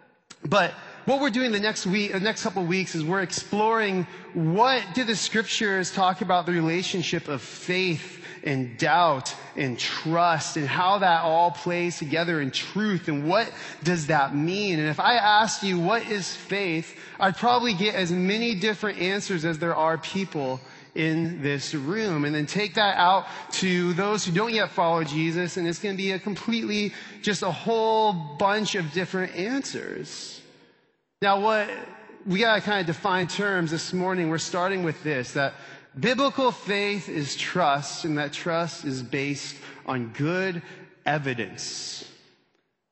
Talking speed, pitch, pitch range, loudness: 165 wpm, 180 Hz, 160-205 Hz, -25 LUFS